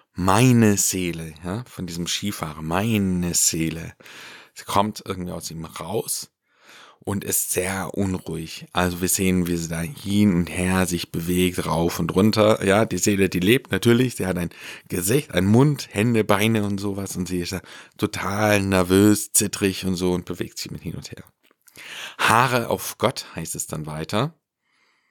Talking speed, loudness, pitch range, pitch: 170 wpm, -22 LUFS, 90-105 Hz, 95 Hz